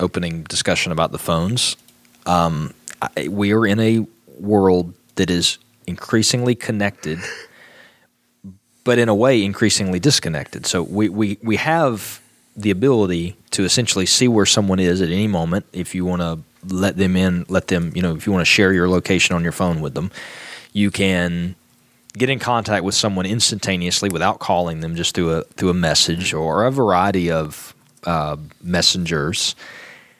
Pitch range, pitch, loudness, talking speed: 85-105 Hz, 95 Hz, -18 LUFS, 165 wpm